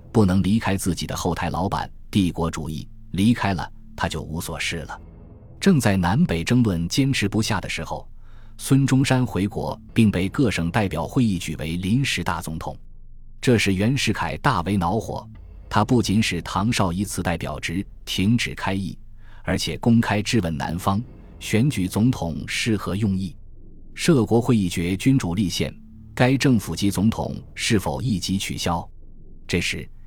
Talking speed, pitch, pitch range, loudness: 240 characters per minute, 100 Hz, 85-110 Hz, -22 LUFS